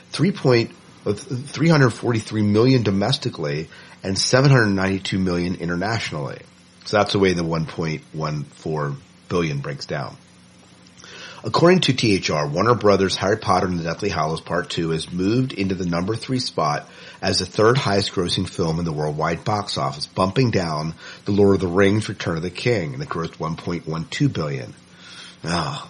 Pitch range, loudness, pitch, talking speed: 80-120 Hz, -21 LUFS, 95 Hz, 155 wpm